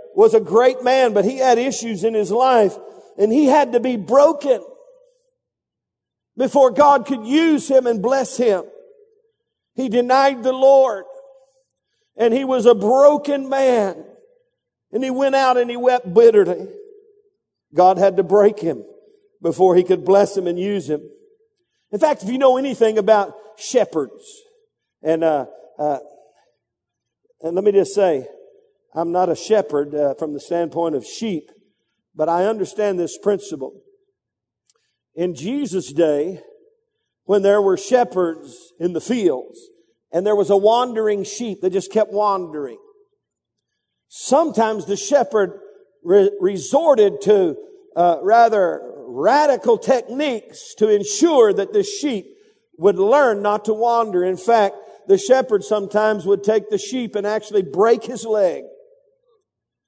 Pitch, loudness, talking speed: 245 Hz, -17 LUFS, 140 wpm